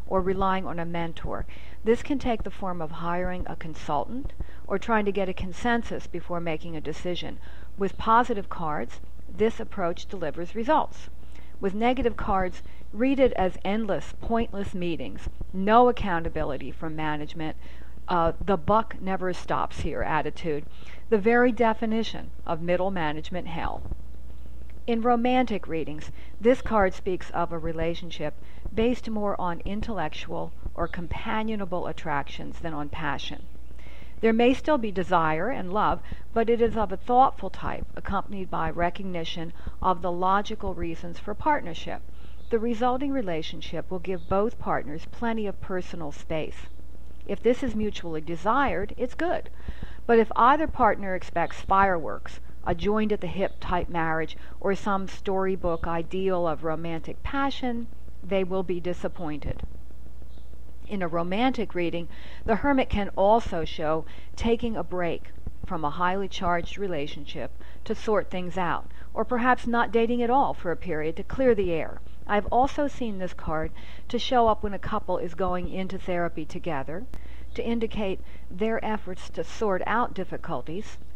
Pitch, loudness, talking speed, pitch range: 185 Hz, -28 LUFS, 145 wpm, 165-225 Hz